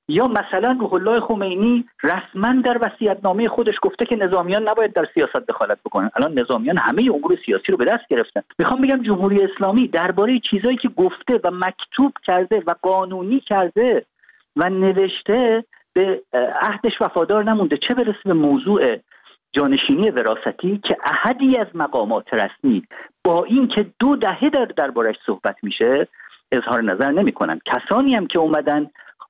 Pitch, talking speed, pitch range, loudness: 220 Hz, 145 wpm, 190-255 Hz, -19 LUFS